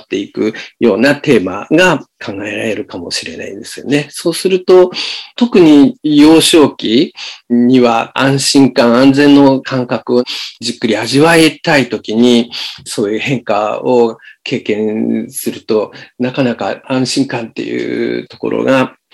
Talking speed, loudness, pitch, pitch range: 280 characters per minute, -12 LUFS, 135 Hz, 120-165 Hz